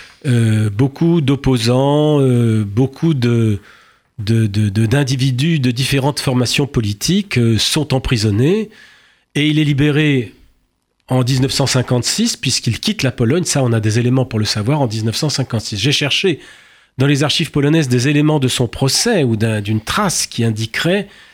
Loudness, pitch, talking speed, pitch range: -15 LUFS, 130 Hz, 150 wpm, 115-145 Hz